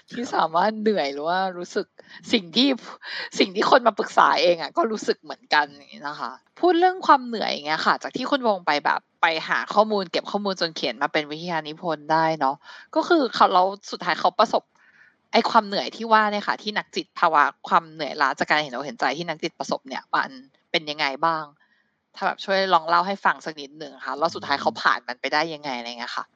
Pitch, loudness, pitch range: 180 Hz, -23 LUFS, 155-220 Hz